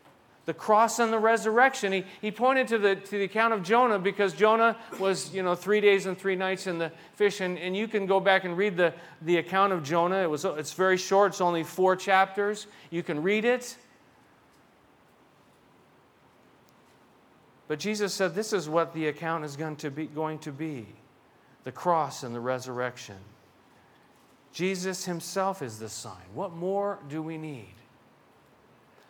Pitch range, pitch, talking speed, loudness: 155-200 Hz, 185 Hz, 175 wpm, -27 LUFS